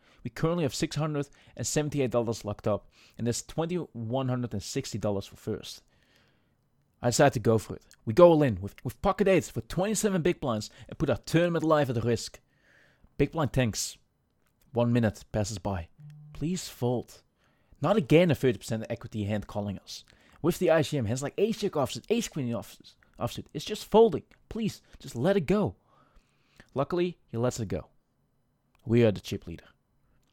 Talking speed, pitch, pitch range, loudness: 160 wpm, 130 Hz, 110-160 Hz, -28 LUFS